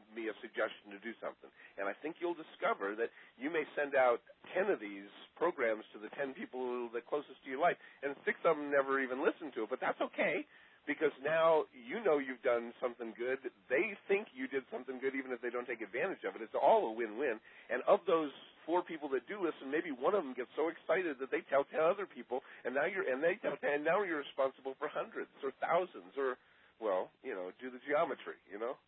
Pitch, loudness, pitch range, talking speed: 135 Hz, -37 LUFS, 120-160 Hz, 230 wpm